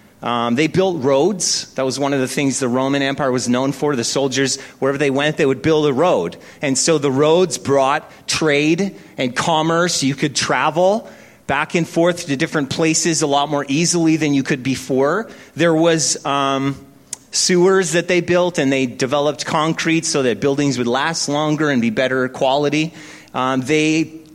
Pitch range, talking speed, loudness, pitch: 135-165 Hz, 180 wpm, -17 LUFS, 145 Hz